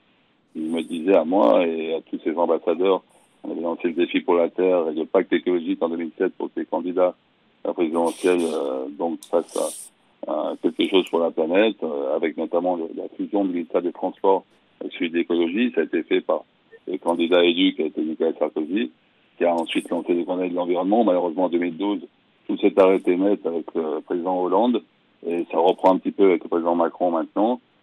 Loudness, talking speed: -22 LUFS, 205 wpm